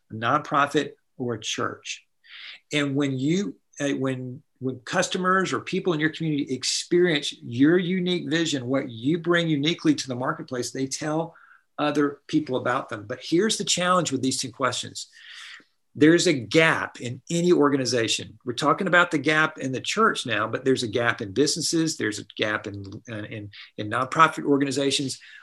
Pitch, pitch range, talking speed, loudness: 145 Hz, 125-160 Hz, 165 wpm, -24 LUFS